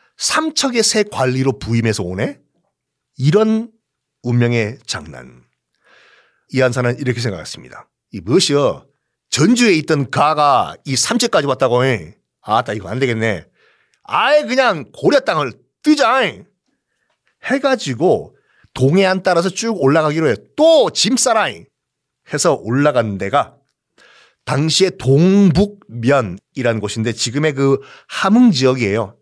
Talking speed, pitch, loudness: 255 characters per minute, 135 Hz, -16 LUFS